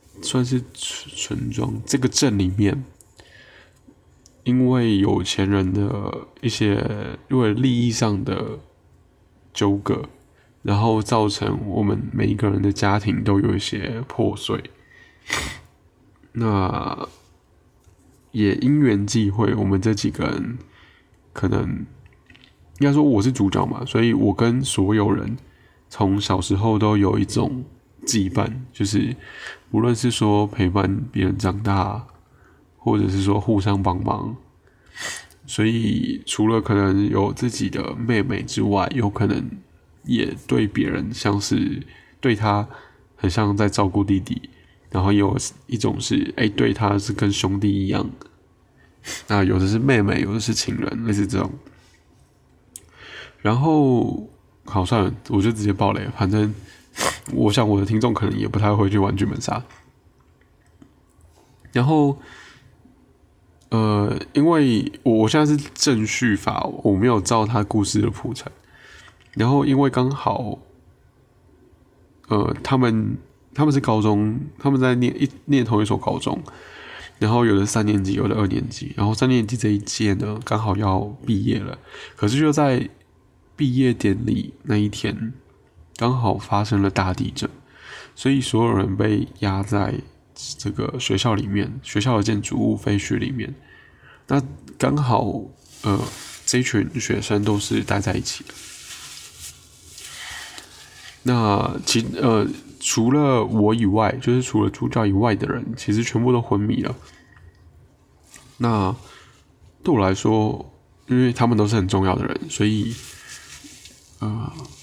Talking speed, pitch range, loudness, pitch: 195 characters per minute, 100-125 Hz, -21 LUFS, 105 Hz